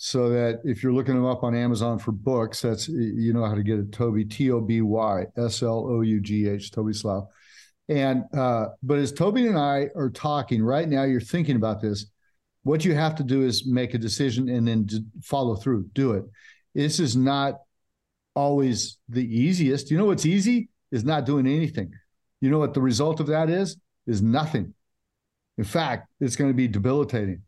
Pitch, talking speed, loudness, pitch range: 125 Hz, 200 wpm, -24 LUFS, 110-140 Hz